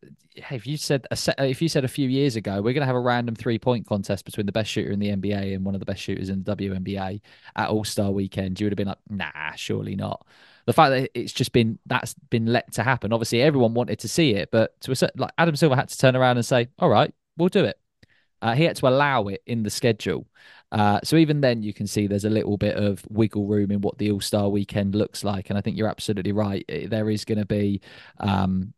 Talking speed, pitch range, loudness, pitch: 260 wpm, 100-130 Hz, -24 LUFS, 110 Hz